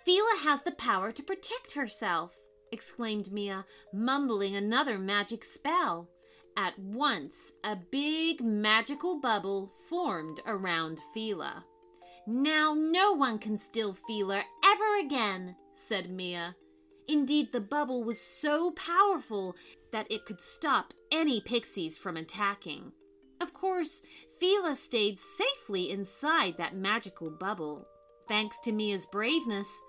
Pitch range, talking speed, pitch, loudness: 190-295 Hz, 120 wpm, 215 Hz, -31 LUFS